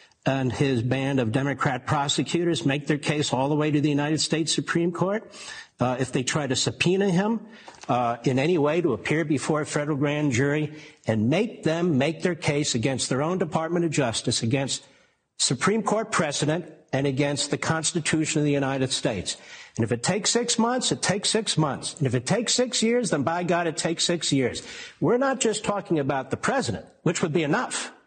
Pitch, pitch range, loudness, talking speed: 155 Hz, 140-175 Hz, -24 LUFS, 200 wpm